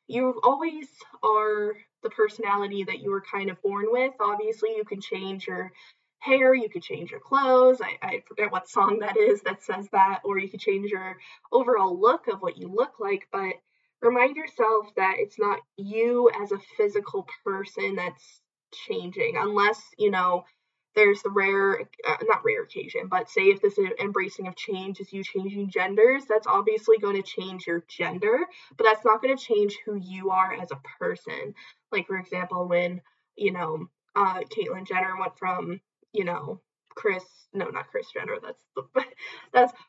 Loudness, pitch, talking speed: -26 LUFS, 220 Hz, 180 wpm